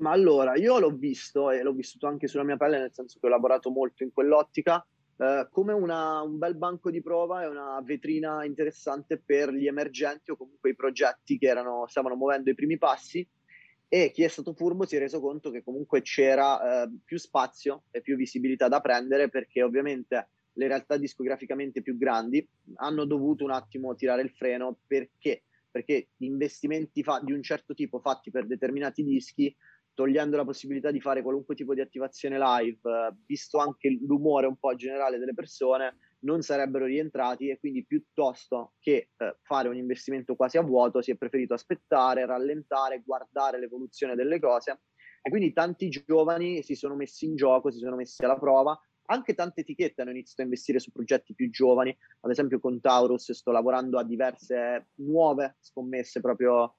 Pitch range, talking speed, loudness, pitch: 130-150 Hz, 180 wpm, -28 LUFS, 140 Hz